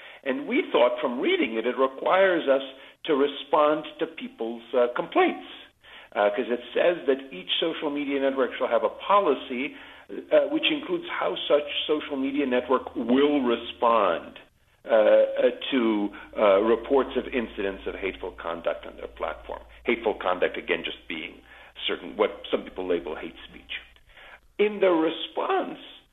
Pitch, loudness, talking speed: 150 Hz, -25 LUFS, 150 wpm